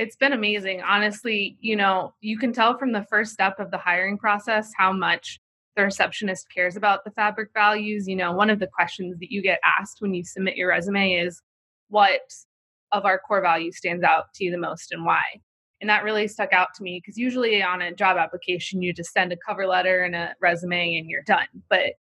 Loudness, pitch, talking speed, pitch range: -23 LUFS, 195 Hz, 220 wpm, 180-210 Hz